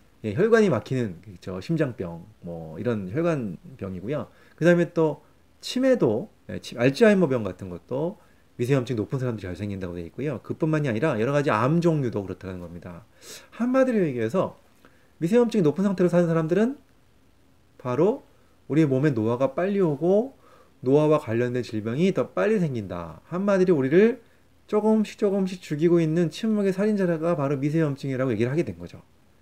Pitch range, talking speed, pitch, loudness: 110-185 Hz, 360 characters per minute, 150 Hz, -24 LUFS